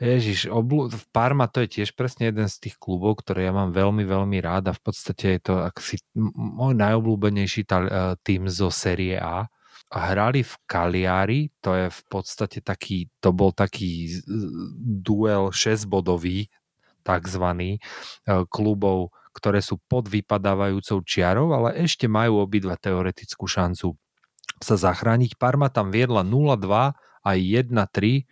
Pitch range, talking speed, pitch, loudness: 95-115 Hz, 140 wpm, 100 Hz, -23 LUFS